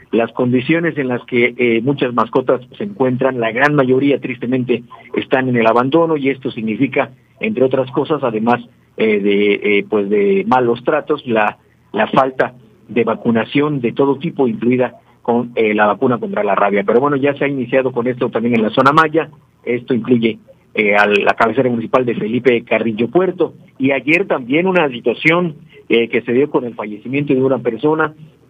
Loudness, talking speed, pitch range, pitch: -15 LUFS, 185 wpm, 115-145 Hz, 125 Hz